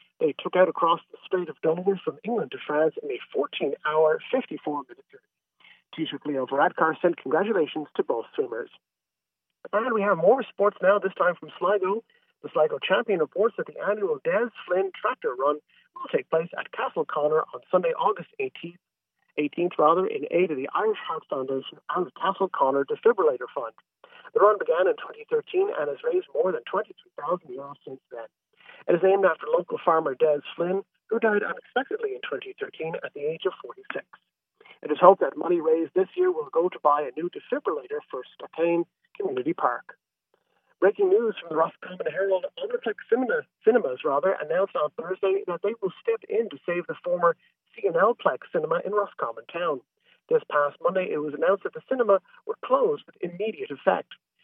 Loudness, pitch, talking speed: -26 LUFS, 375 Hz, 185 wpm